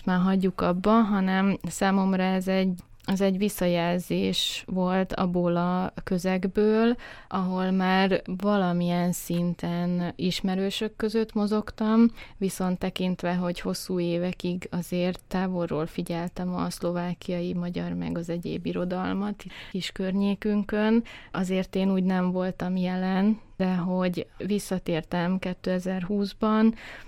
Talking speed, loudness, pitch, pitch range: 105 wpm, -27 LUFS, 185 Hz, 175-195 Hz